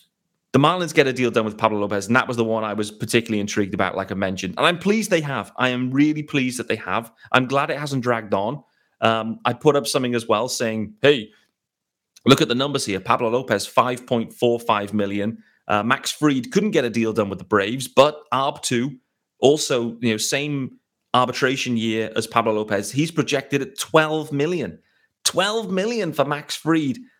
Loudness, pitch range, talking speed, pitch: -21 LUFS, 110-145 Hz, 200 wpm, 125 Hz